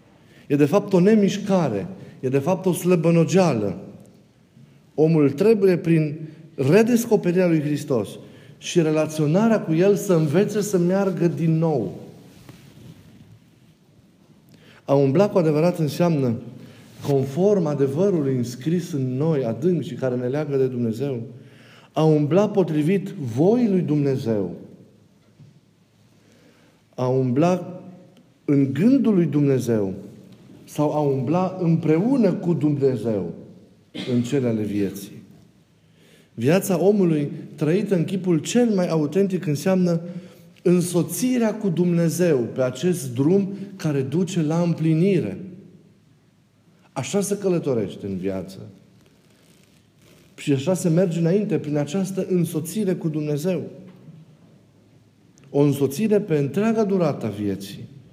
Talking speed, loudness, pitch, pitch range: 105 wpm, -21 LUFS, 165 Hz, 140-185 Hz